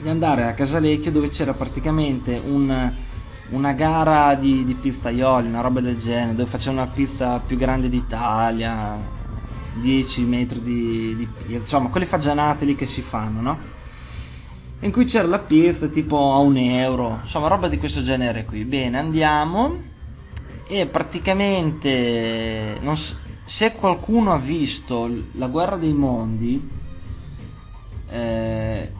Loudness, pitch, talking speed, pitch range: -21 LUFS, 125 Hz, 135 wpm, 115-145 Hz